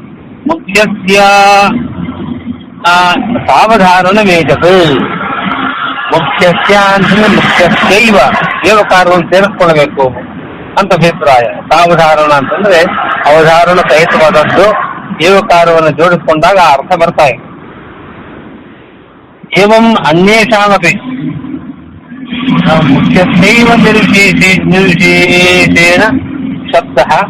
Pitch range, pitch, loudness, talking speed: 165-210 Hz, 185 Hz, -6 LUFS, 55 wpm